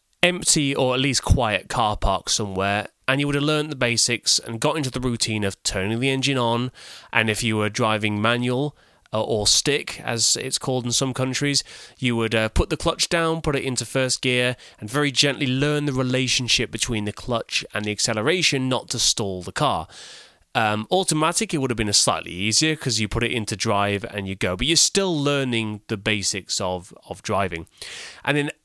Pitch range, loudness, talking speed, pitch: 110-140 Hz, -21 LUFS, 205 wpm, 125 Hz